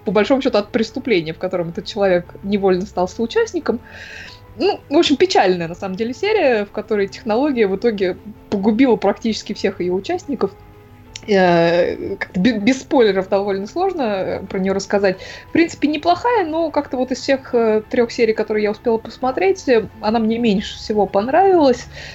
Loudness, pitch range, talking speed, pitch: -18 LUFS, 195-265 Hz, 160 wpm, 220 Hz